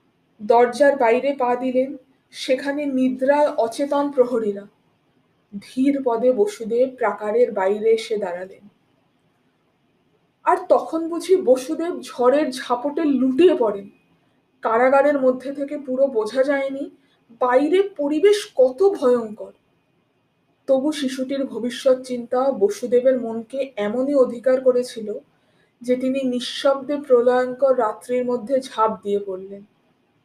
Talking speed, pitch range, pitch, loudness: 100 wpm, 230-280 Hz, 255 Hz, -20 LUFS